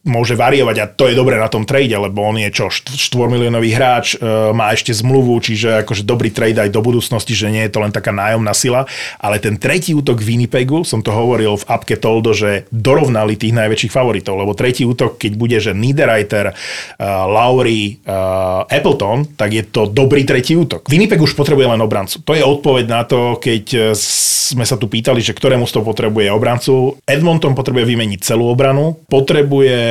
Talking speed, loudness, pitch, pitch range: 195 wpm, -13 LUFS, 115 Hz, 110-130 Hz